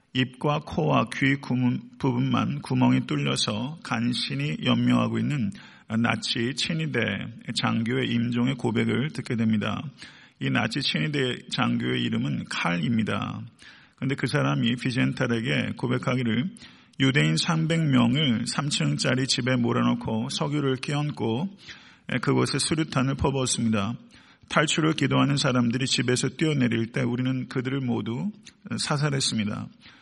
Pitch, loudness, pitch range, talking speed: 130 Hz, -25 LUFS, 120-145 Hz, 280 characters per minute